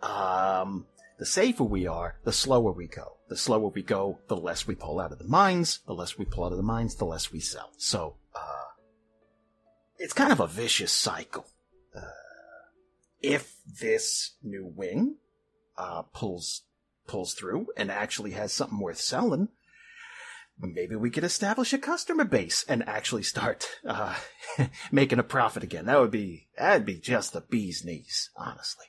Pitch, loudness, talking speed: 170 Hz, -28 LUFS, 170 wpm